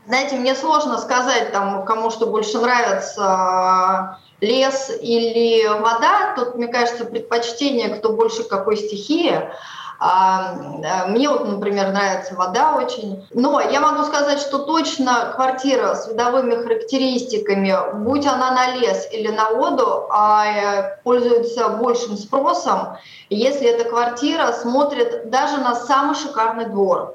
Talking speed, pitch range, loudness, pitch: 120 wpm, 210-265 Hz, -18 LUFS, 235 Hz